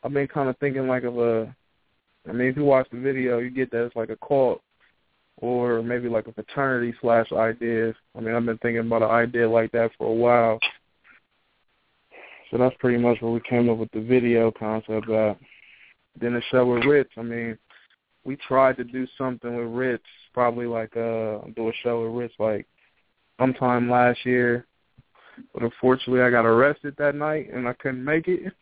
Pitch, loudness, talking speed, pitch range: 120 Hz, -23 LUFS, 195 wpm, 115-130 Hz